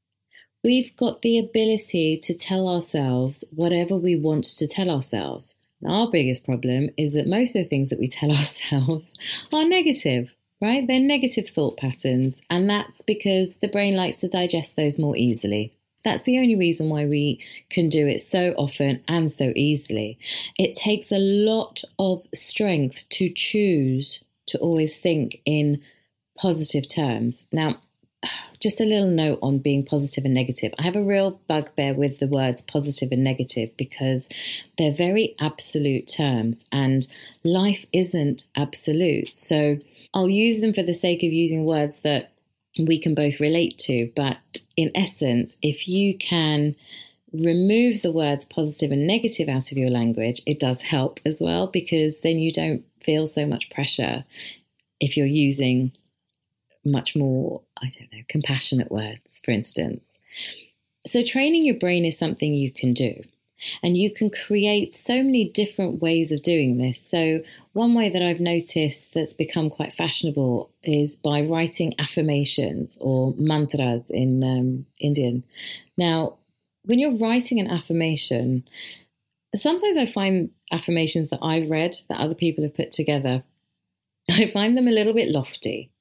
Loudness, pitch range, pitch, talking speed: -22 LUFS, 135-185 Hz, 155 Hz, 155 wpm